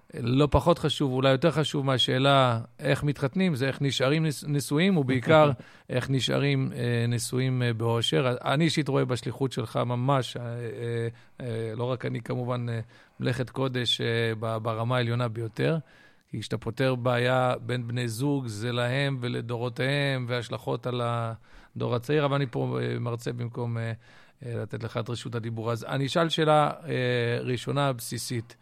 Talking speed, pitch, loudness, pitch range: 130 wpm, 125 Hz, -27 LUFS, 120-140 Hz